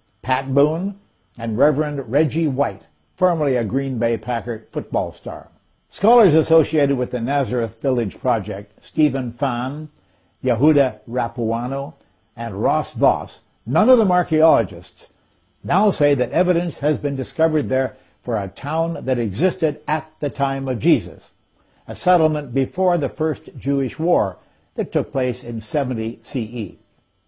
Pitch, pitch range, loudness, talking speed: 135 Hz, 115-155 Hz, -20 LUFS, 135 wpm